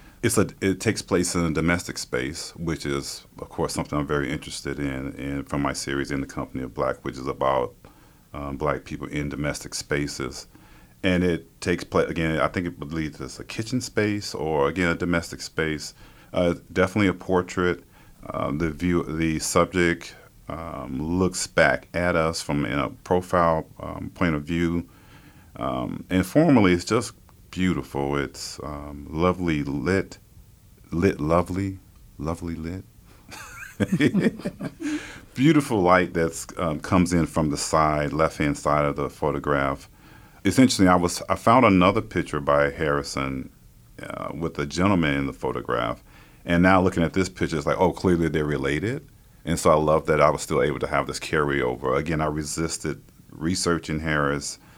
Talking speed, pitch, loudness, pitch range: 165 wpm, 85 Hz, -24 LUFS, 75-90 Hz